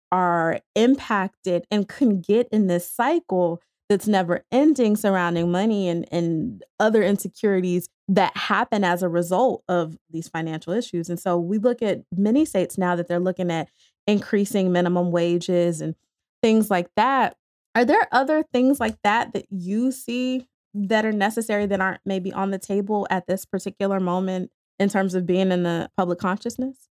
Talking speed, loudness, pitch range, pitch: 165 wpm, -22 LUFS, 175-215 Hz, 195 Hz